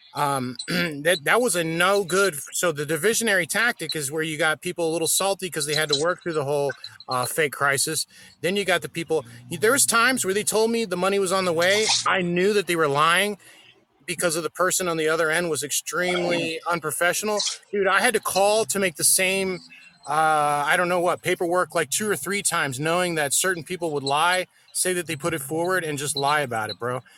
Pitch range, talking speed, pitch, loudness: 155-190 Hz, 225 wpm, 175 Hz, -22 LUFS